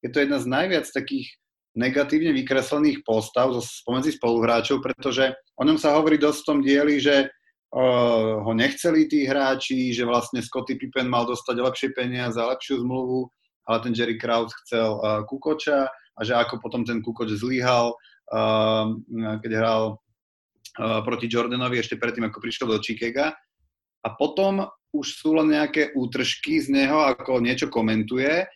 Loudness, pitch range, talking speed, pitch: -23 LUFS, 115-140 Hz, 155 wpm, 125 Hz